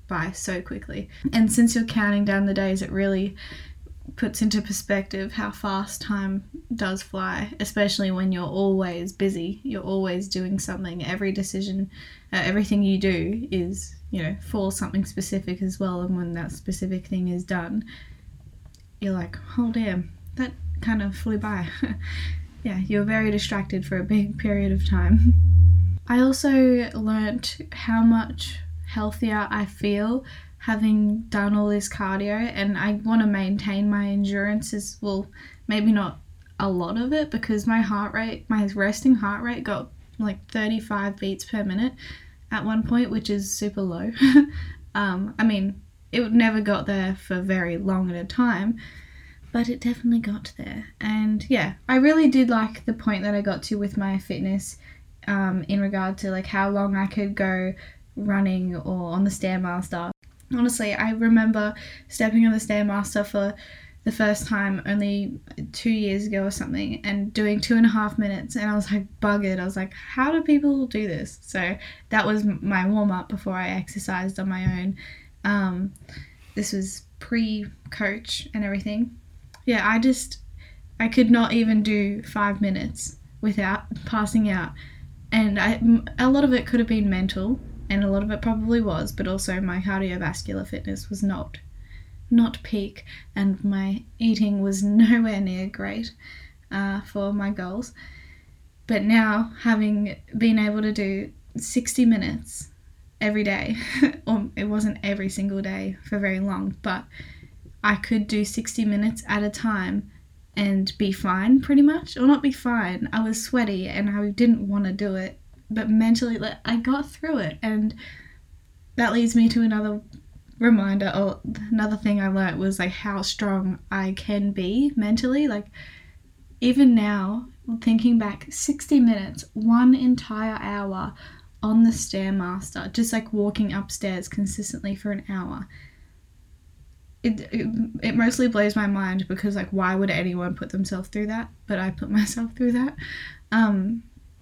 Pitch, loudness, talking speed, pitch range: 205 Hz, -24 LUFS, 160 wpm, 190-220 Hz